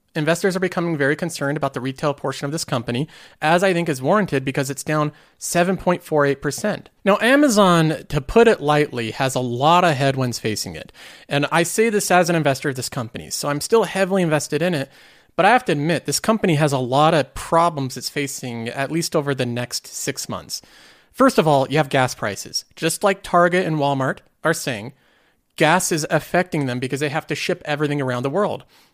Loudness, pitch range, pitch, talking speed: -20 LUFS, 135-175 Hz, 150 Hz, 205 wpm